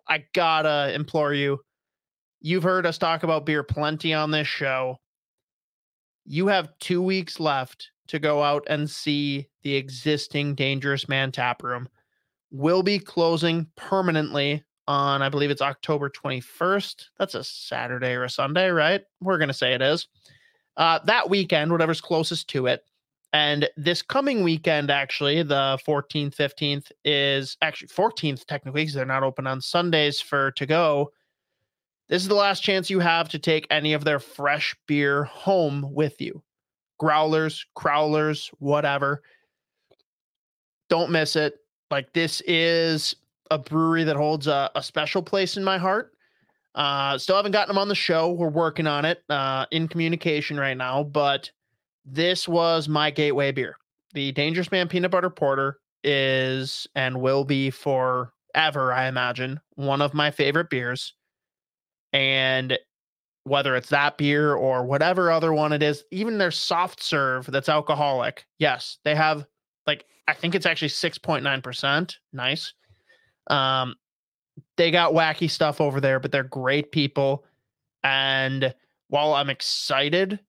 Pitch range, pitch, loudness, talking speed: 140-165 Hz, 150 Hz, -23 LUFS, 150 wpm